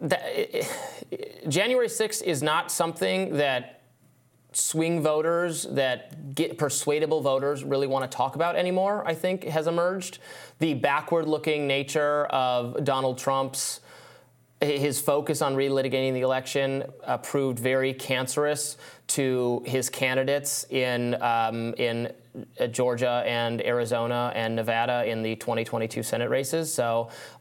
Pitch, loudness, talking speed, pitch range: 135 Hz, -26 LUFS, 125 wpm, 125-155 Hz